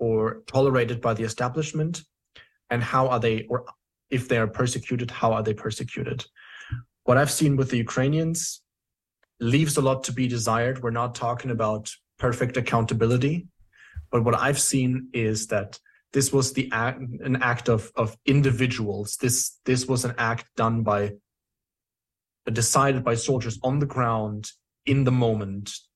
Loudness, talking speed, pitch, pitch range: -25 LUFS, 155 wpm, 125 Hz, 115-130 Hz